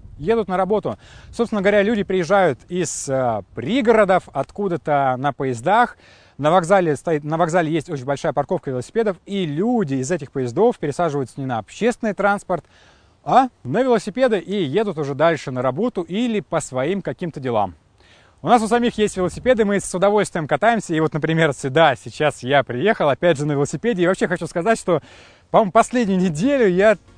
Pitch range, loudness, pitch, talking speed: 145-210 Hz, -19 LUFS, 180 Hz, 170 wpm